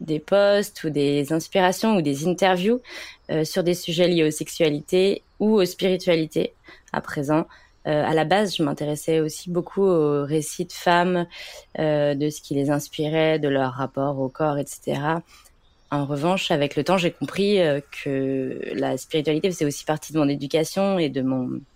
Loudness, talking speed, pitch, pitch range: -23 LUFS, 175 wpm, 155 Hz, 145-180 Hz